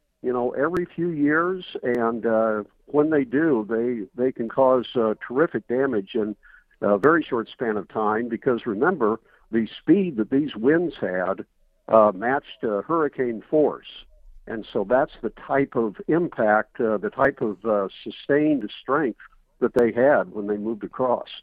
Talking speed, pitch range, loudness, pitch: 160 wpm, 110-140 Hz, -23 LUFS, 120 Hz